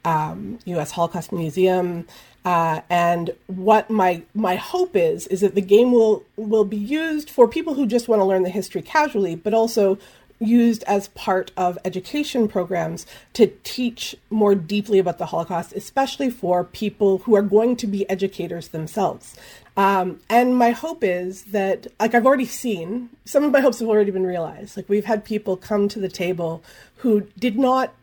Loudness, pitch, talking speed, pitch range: -21 LUFS, 205 Hz, 180 wpm, 180-235 Hz